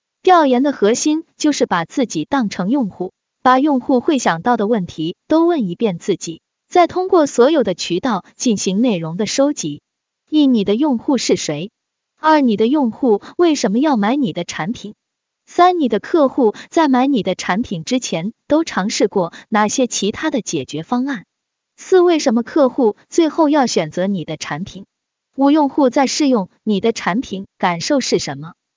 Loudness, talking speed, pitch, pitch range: -16 LUFS, 250 characters per minute, 245 Hz, 195-280 Hz